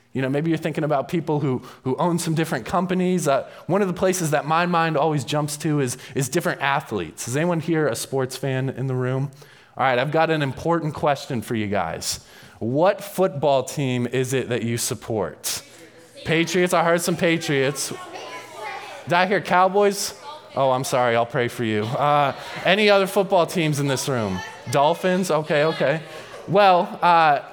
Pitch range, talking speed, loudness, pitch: 130-175 Hz, 185 wpm, -22 LUFS, 150 Hz